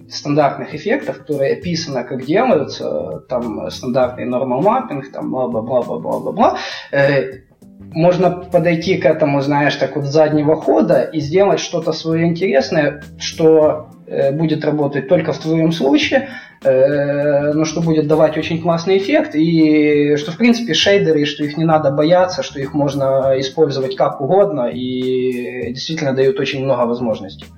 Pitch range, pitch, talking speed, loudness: 135-165 Hz, 150 Hz, 135 wpm, -16 LUFS